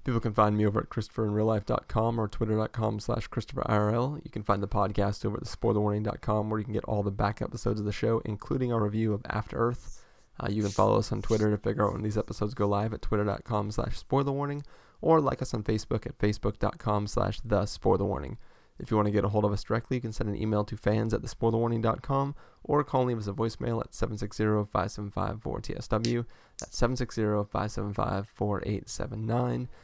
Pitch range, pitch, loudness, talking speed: 105-120 Hz, 110 Hz, -30 LUFS, 190 wpm